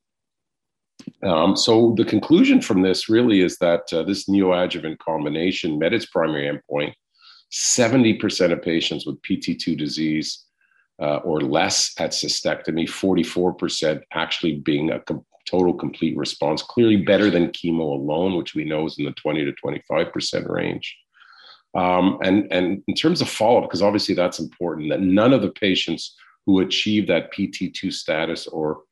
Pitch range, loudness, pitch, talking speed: 80-100 Hz, -21 LUFS, 90 Hz, 155 wpm